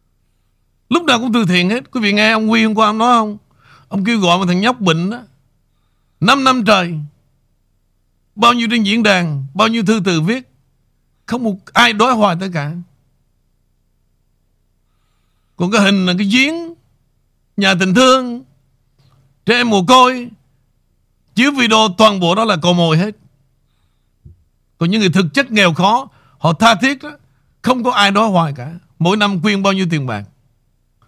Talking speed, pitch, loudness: 175 wpm, 185 Hz, -13 LUFS